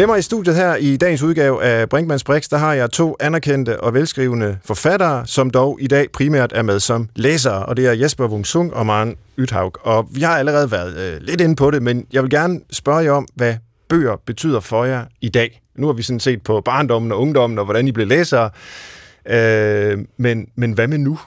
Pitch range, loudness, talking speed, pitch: 115-150 Hz, -17 LUFS, 225 wpm, 130 Hz